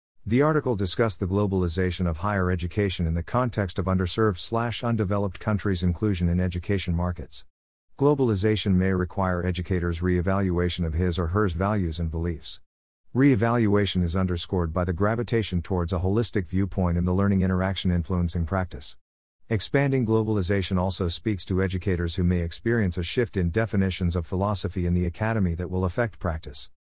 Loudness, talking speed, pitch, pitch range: -25 LUFS, 155 wpm, 95 Hz, 90-105 Hz